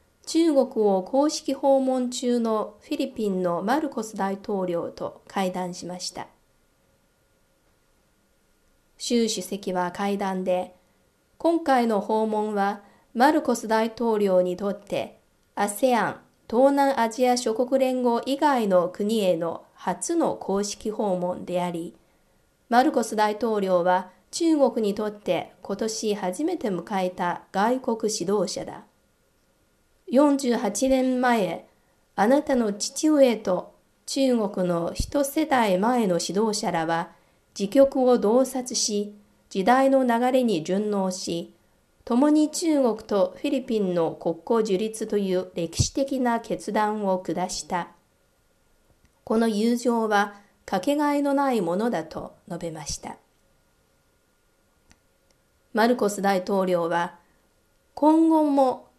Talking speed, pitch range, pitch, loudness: 210 characters per minute, 185-260 Hz, 220 Hz, -24 LUFS